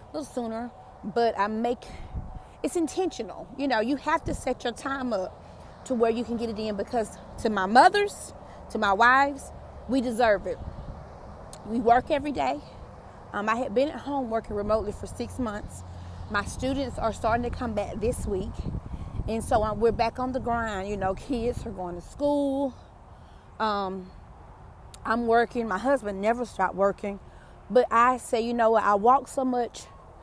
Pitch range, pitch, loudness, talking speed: 210-260 Hz, 235 Hz, -27 LUFS, 175 wpm